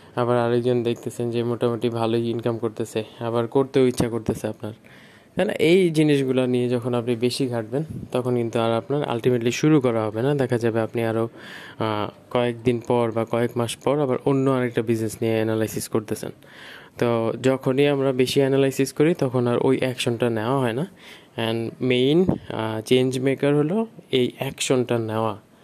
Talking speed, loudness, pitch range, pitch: 165 wpm, -23 LUFS, 115-135 Hz, 120 Hz